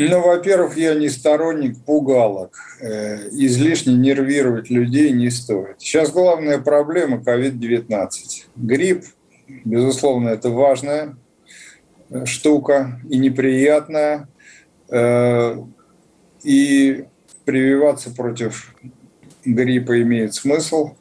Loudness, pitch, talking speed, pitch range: -17 LUFS, 135 Hz, 80 wpm, 120-150 Hz